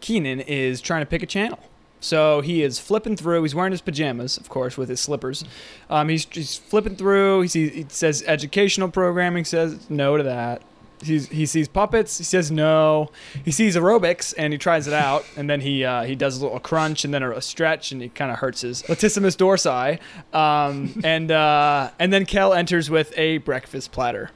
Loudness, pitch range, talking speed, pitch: -21 LUFS, 145-180 Hz, 205 wpm, 155 Hz